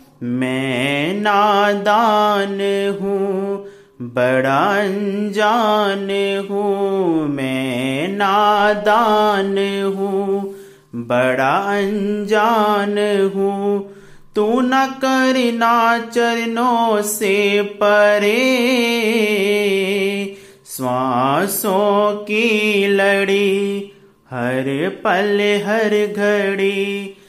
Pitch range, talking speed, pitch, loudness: 195-210 Hz, 55 wpm, 200 Hz, -17 LUFS